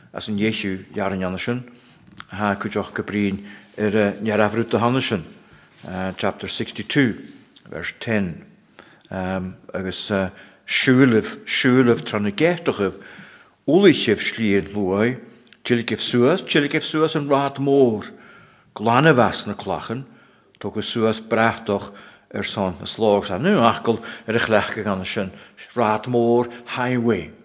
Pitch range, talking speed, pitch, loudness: 100-120 Hz, 135 wpm, 110 Hz, -21 LUFS